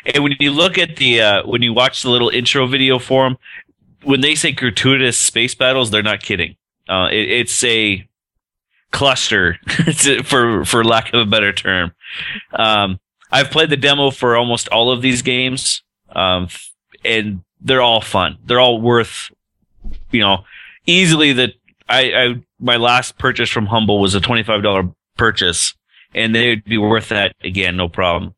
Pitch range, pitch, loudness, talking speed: 105-130 Hz, 120 Hz, -14 LUFS, 170 wpm